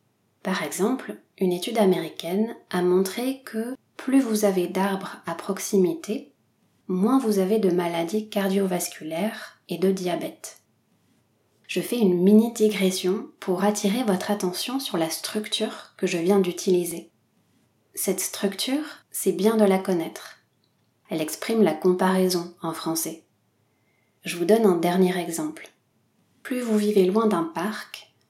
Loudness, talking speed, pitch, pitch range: -24 LUFS, 135 wpm, 195 Hz, 180-215 Hz